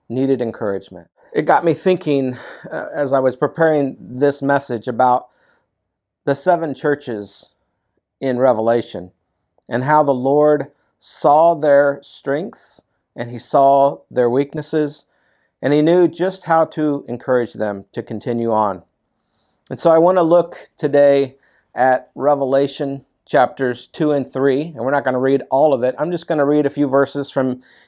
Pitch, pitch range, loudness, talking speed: 140 Hz, 125-150 Hz, -17 LUFS, 155 wpm